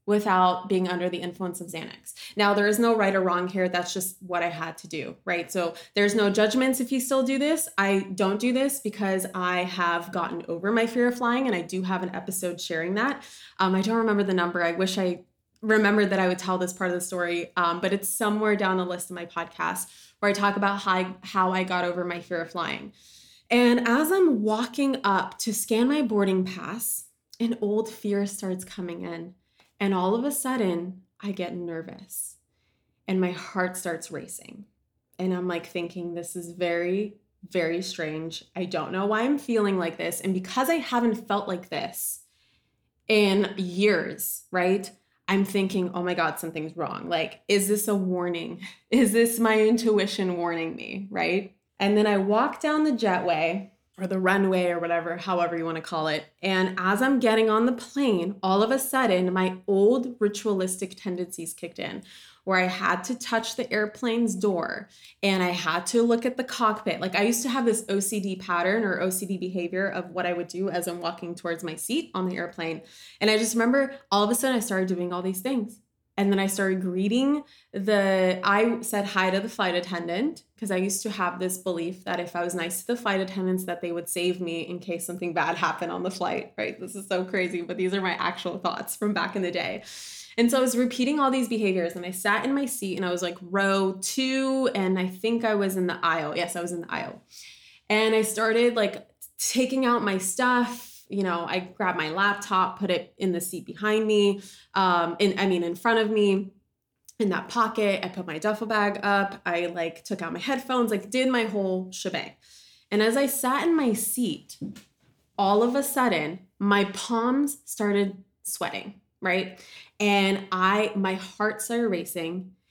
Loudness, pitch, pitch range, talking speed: -26 LUFS, 195 Hz, 180-220 Hz, 205 wpm